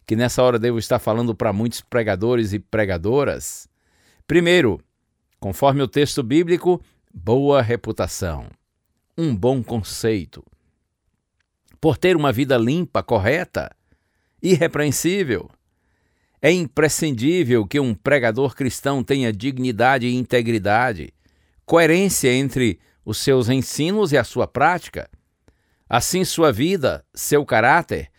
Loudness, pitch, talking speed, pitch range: -19 LUFS, 125 Hz, 110 wpm, 110-150 Hz